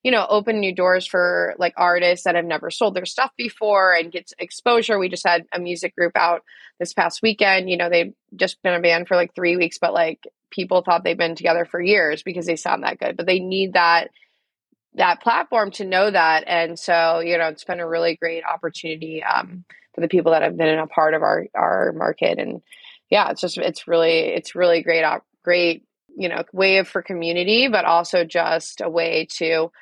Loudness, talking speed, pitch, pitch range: -19 LUFS, 215 wpm, 175 Hz, 165-190 Hz